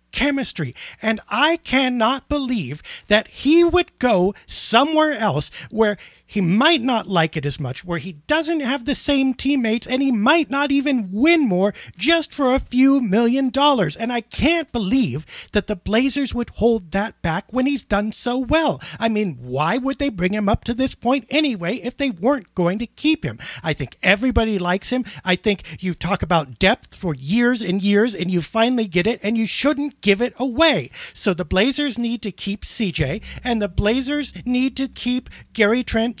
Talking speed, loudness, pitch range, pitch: 190 wpm, -20 LUFS, 200-270 Hz, 235 Hz